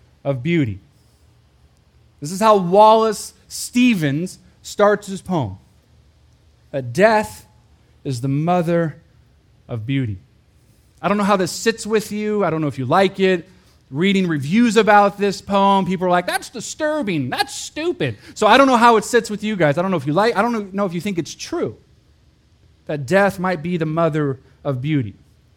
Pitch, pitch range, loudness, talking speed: 185 Hz, 150-210 Hz, -18 LUFS, 180 wpm